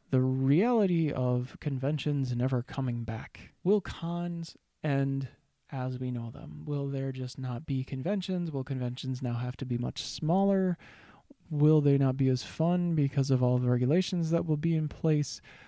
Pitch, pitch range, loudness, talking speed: 140 Hz, 130-165 Hz, -30 LUFS, 170 wpm